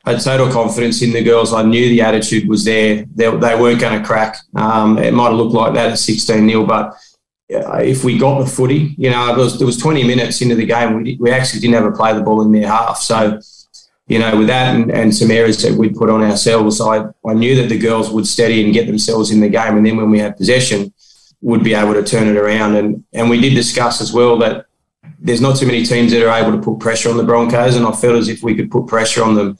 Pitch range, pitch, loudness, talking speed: 110-120 Hz, 115 Hz, -13 LUFS, 270 wpm